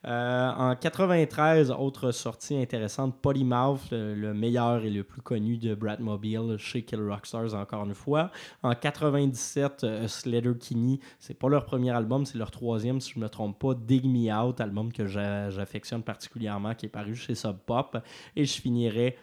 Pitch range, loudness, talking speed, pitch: 110-130 Hz, -29 LUFS, 185 wpm, 120 Hz